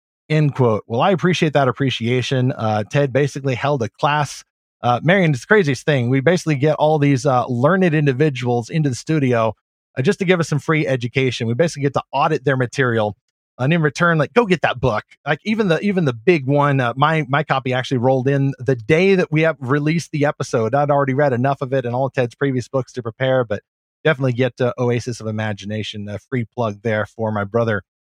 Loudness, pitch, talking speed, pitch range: -18 LUFS, 135 Hz, 225 wpm, 120-155 Hz